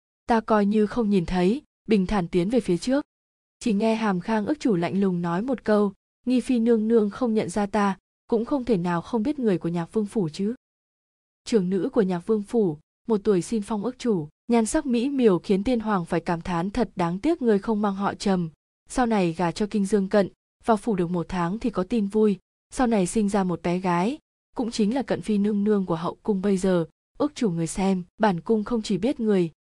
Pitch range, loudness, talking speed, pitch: 185-230 Hz, -24 LUFS, 240 wpm, 210 Hz